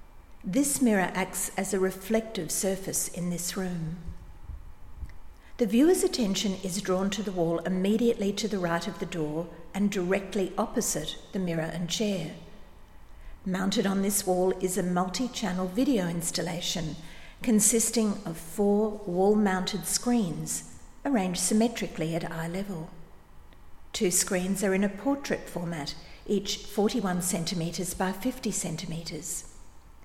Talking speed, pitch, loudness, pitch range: 130 wpm, 190 Hz, -28 LUFS, 170-210 Hz